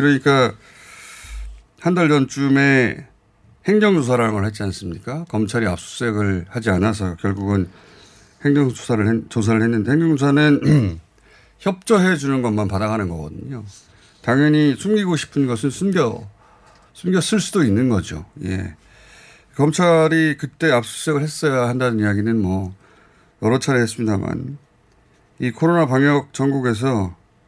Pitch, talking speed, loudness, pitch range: 120 Hz, 280 characters per minute, -18 LUFS, 105-145 Hz